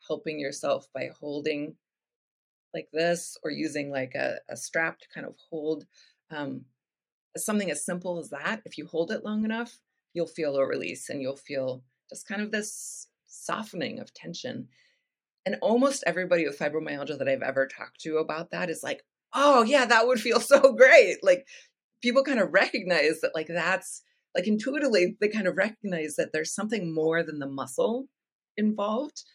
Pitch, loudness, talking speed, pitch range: 180 Hz, -27 LUFS, 175 wpm, 155-240 Hz